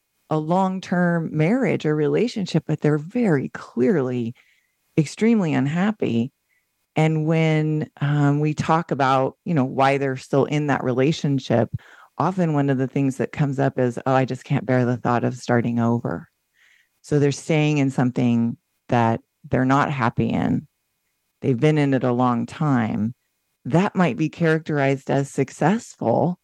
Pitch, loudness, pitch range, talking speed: 140 Hz, -21 LUFS, 125-155 Hz, 155 wpm